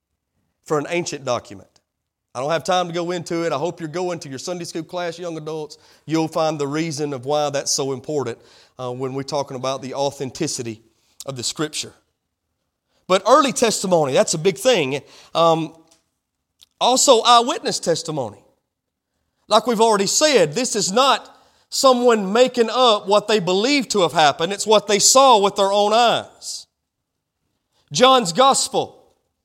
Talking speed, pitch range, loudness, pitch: 160 wpm, 140-220 Hz, -18 LUFS, 170 Hz